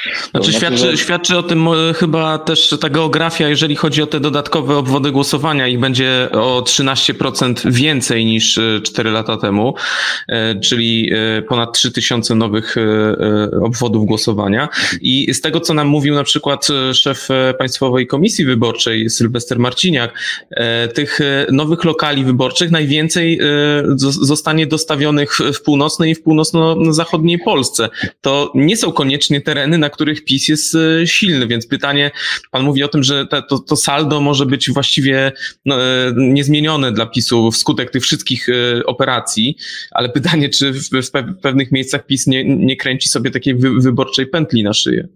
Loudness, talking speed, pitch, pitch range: -13 LUFS, 145 wpm, 140 Hz, 125-155 Hz